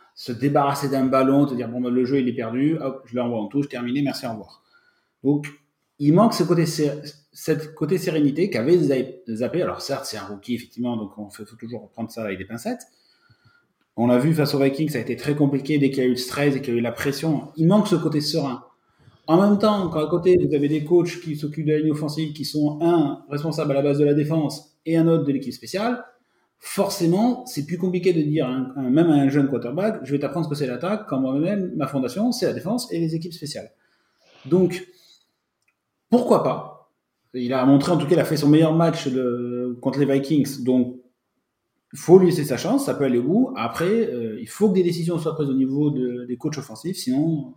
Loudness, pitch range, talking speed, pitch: -22 LUFS, 130-170 Hz, 235 wpm, 145 Hz